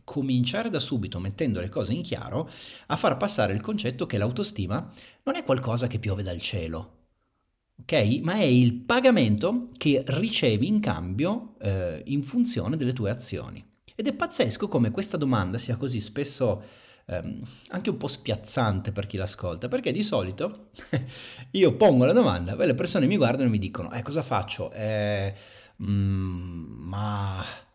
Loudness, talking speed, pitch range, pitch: -25 LUFS, 160 wpm, 100-135 Hz, 110 Hz